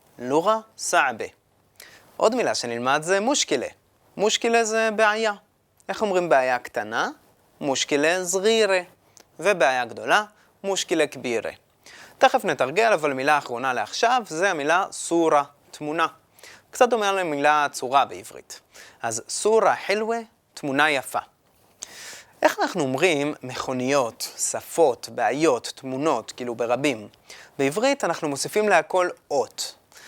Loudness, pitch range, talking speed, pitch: -23 LUFS, 140-205 Hz, 110 wpm, 160 Hz